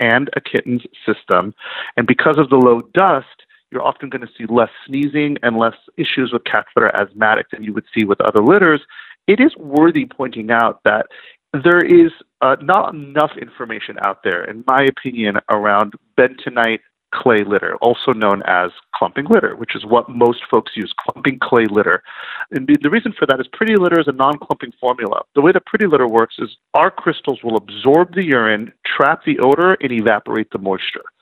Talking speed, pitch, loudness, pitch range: 190 wpm, 135 Hz, -15 LUFS, 115-165 Hz